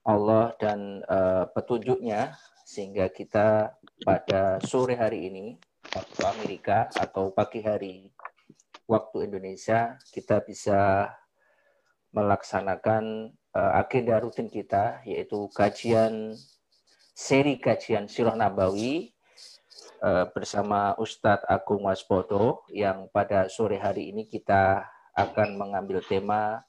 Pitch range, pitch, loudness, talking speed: 100-110 Hz, 105 Hz, -27 LUFS, 100 wpm